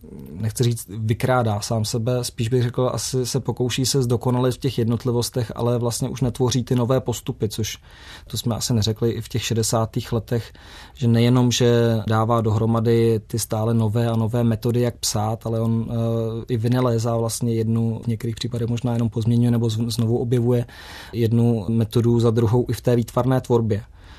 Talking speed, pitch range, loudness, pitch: 180 wpm, 115-120 Hz, -21 LUFS, 115 Hz